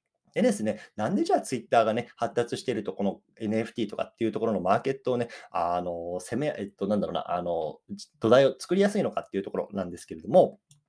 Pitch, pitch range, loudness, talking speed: 120 Hz, 110-145 Hz, -28 LUFS, 470 characters per minute